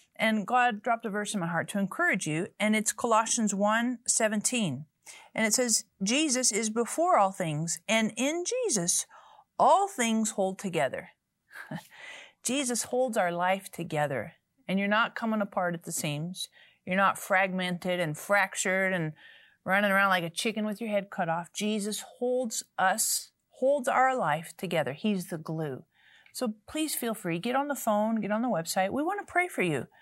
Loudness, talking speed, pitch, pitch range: -28 LUFS, 175 wpm, 210 Hz, 185-245 Hz